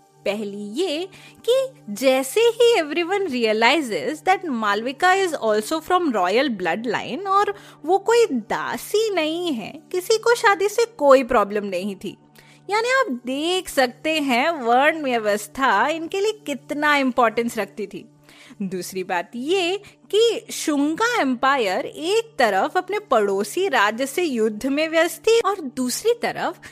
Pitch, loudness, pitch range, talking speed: 295 Hz, -21 LUFS, 235-375 Hz, 135 wpm